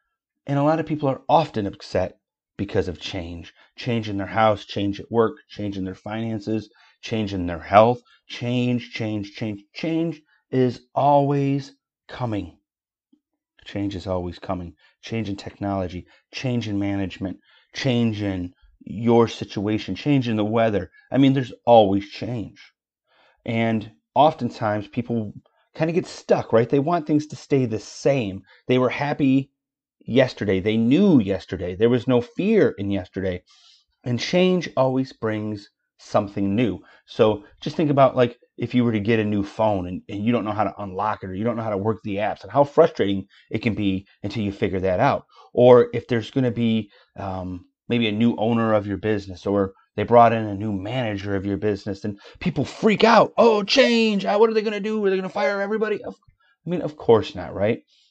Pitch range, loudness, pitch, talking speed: 100-135 Hz, -22 LUFS, 115 Hz, 185 wpm